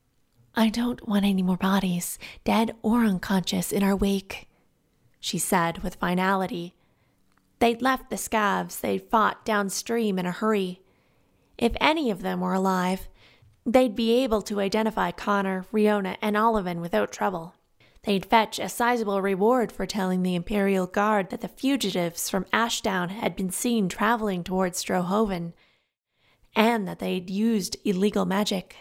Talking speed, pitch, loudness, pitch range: 145 wpm, 200 Hz, -25 LUFS, 185-220 Hz